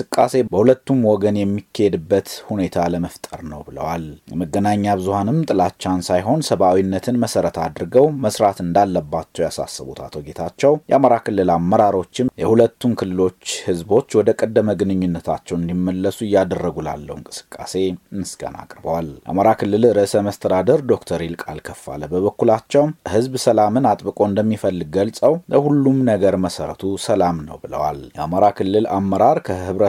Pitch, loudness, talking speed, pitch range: 100 Hz, -18 LUFS, 115 wpm, 90-115 Hz